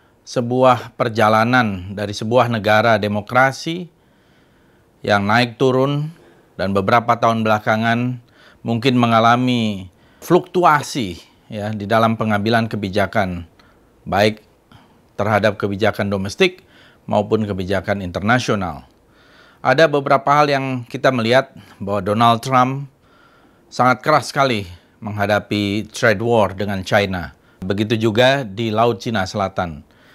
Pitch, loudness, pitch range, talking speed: 115 Hz, -17 LUFS, 100-125 Hz, 100 wpm